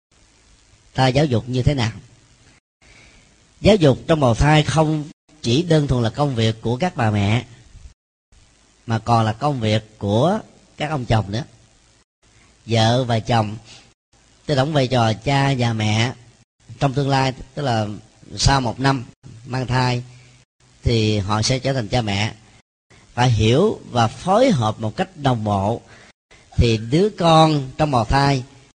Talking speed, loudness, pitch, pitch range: 155 wpm, -19 LUFS, 120 Hz, 110-140 Hz